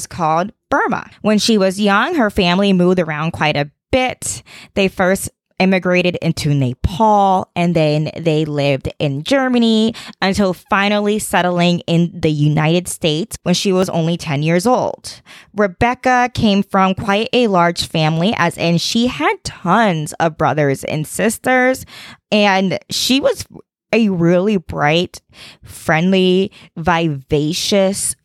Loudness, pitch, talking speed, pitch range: -16 LUFS, 185 Hz, 130 wpm, 165-210 Hz